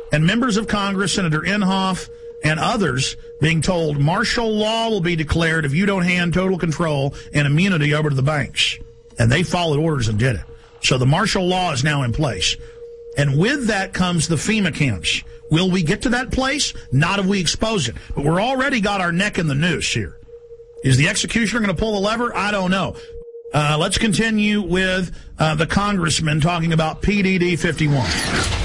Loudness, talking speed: -19 LUFS, 195 wpm